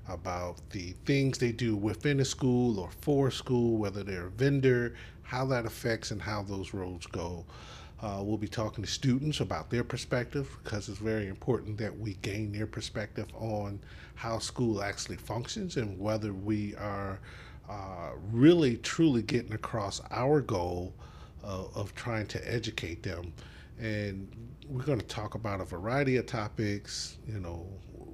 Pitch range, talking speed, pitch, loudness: 95-120 Hz, 160 wpm, 110 Hz, -32 LUFS